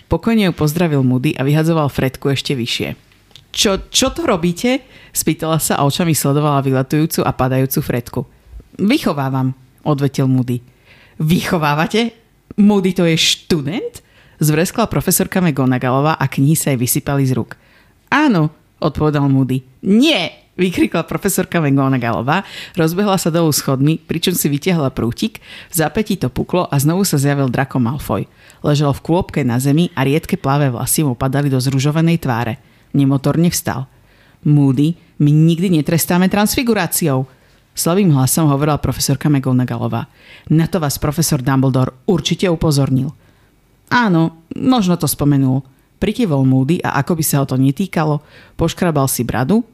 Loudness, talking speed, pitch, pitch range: -16 LUFS, 140 wpm, 150 Hz, 130-170 Hz